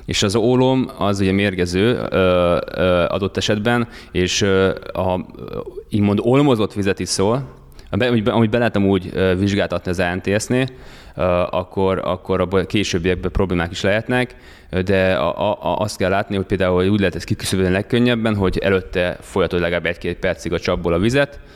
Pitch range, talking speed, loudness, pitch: 90-110 Hz, 155 wpm, -19 LUFS, 95 Hz